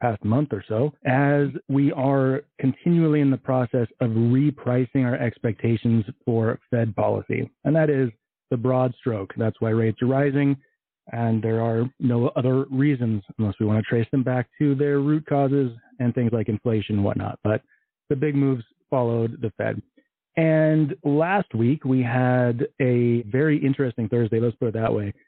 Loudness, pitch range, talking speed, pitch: -23 LUFS, 115-140 Hz, 175 wpm, 125 Hz